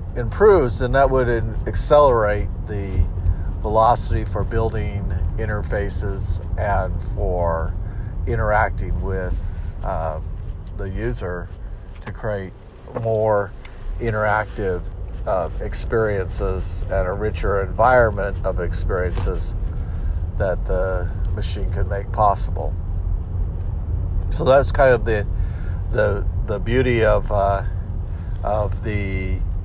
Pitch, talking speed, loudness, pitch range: 95 Hz, 95 wpm, -22 LUFS, 90-105 Hz